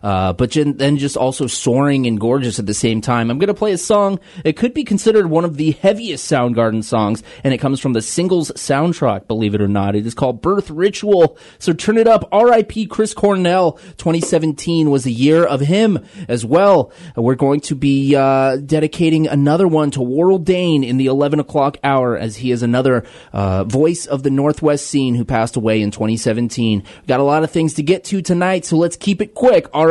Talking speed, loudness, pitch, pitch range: 215 wpm, -16 LUFS, 145 Hz, 125-175 Hz